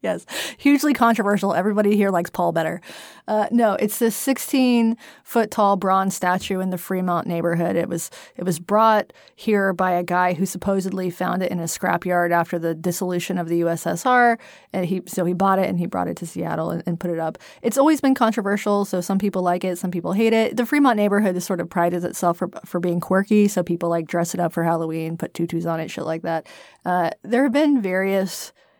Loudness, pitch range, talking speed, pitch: -21 LUFS, 175-210 Hz, 215 wpm, 185 Hz